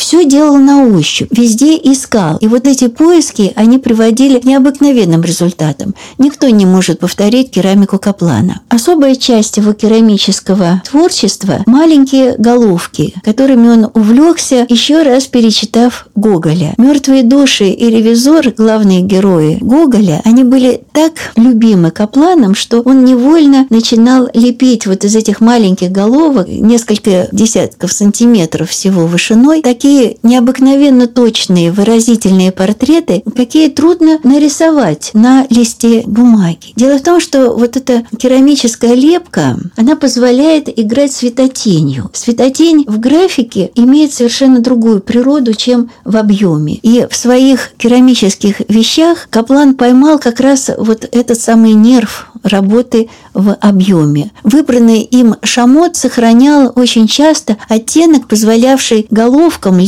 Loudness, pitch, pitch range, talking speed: -8 LUFS, 235 Hz, 210-270 Hz, 120 wpm